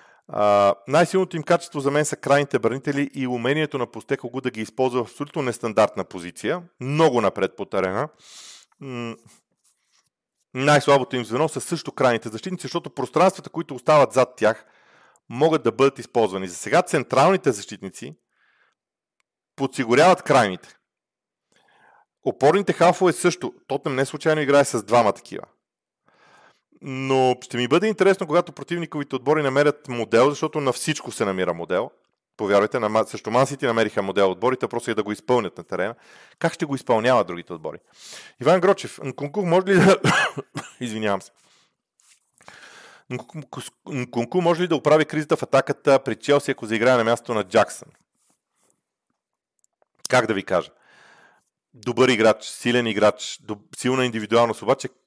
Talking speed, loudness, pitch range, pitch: 140 wpm, -21 LUFS, 120-155 Hz, 135 Hz